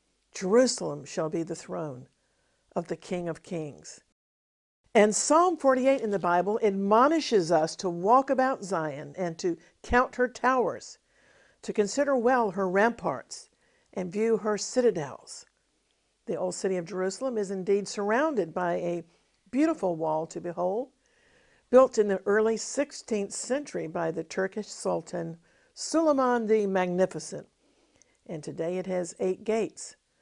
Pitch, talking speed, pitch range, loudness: 200 Hz, 135 wpm, 175-250 Hz, -27 LUFS